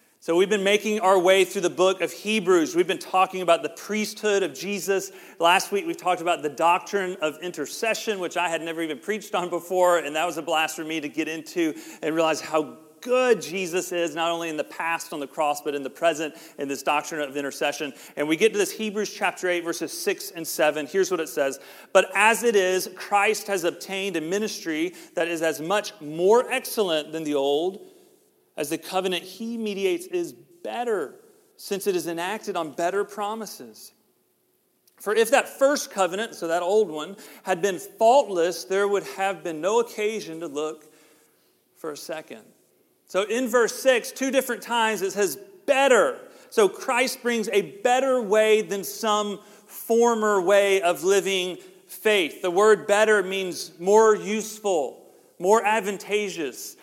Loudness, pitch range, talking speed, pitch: -24 LUFS, 170-225 Hz, 180 wpm, 195 Hz